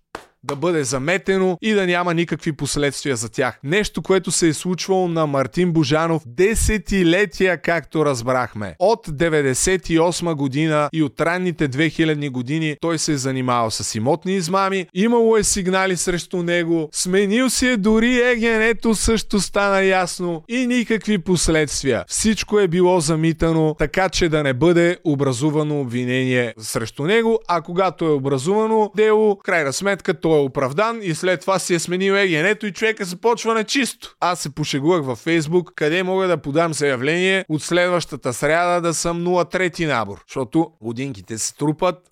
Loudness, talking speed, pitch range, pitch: -19 LUFS, 155 wpm, 150-190 Hz, 170 Hz